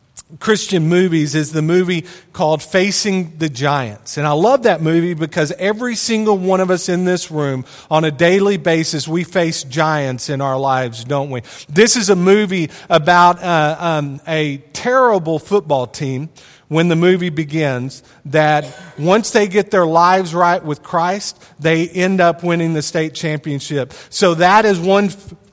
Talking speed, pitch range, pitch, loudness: 165 wpm, 150-185 Hz, 165 Hz, -15 LUFS